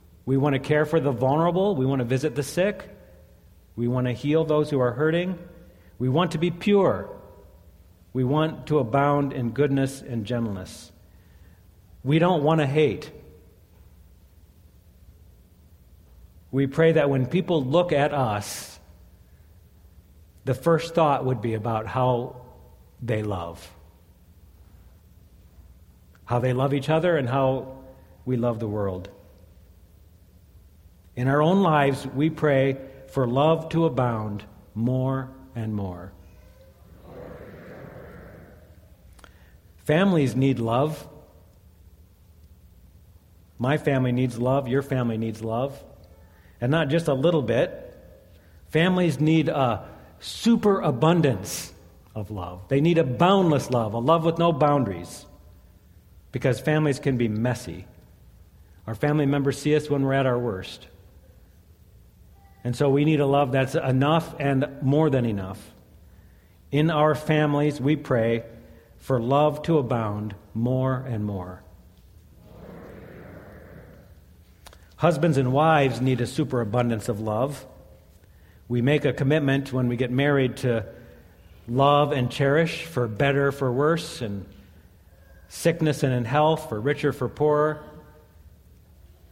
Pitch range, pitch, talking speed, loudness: 90-145 Hz, 120 Hz, 125 wpm, -24 LUFS